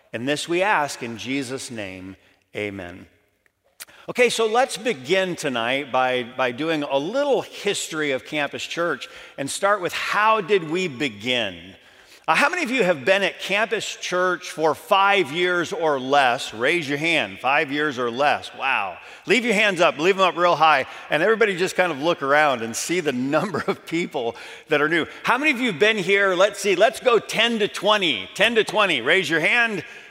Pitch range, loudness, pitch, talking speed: 140-200 Hz, -21 LUFS, 170 Hz, 195 wpm